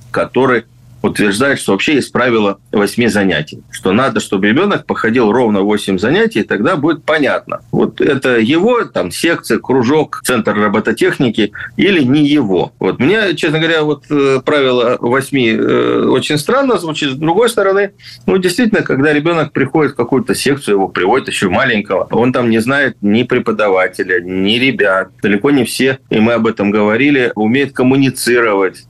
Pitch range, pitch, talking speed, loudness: 110-145 Hz, 125 Hz, 155 wpm, -13 LUFS